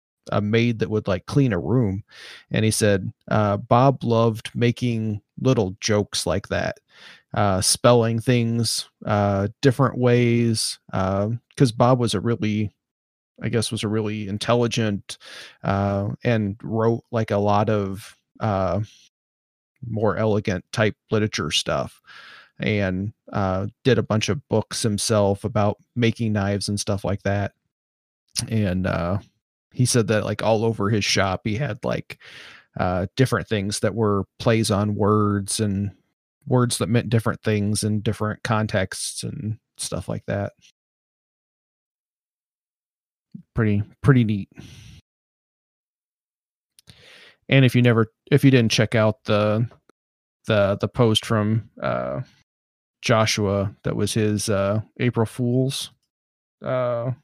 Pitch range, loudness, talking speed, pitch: 100-115 Hz, -22 LUFS, 130 wpm, 105 Hz